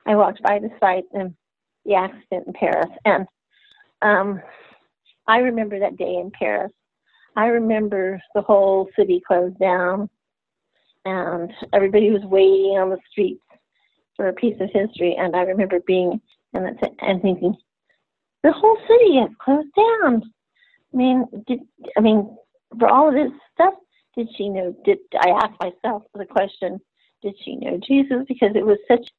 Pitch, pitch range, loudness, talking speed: 210 Hz, 190-250 Hz, -19 LUFS, 160 wpm